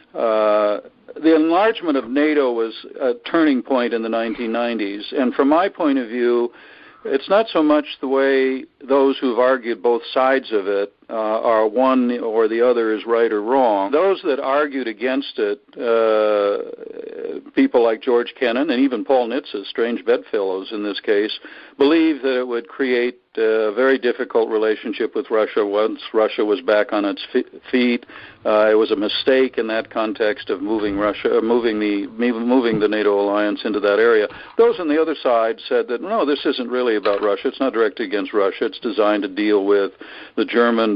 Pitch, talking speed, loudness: 125 Hz, 190 wpm, -19 LUFS